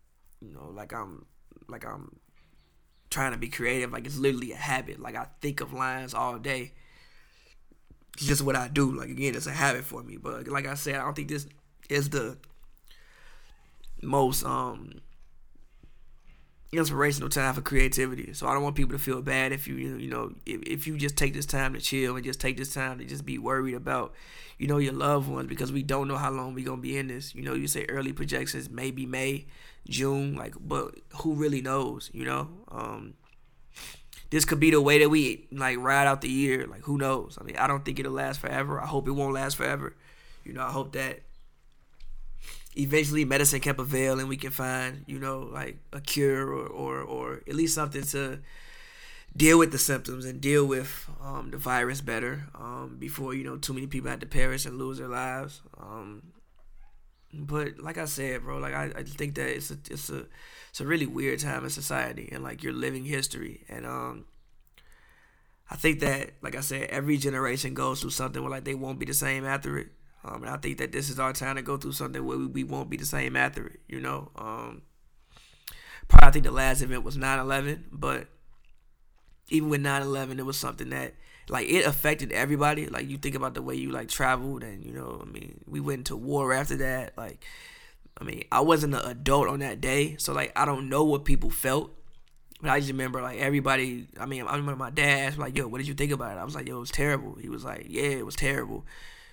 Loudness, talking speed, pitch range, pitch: -29 LUFS, 220 wpm, 130-145 Hz, 135 Hz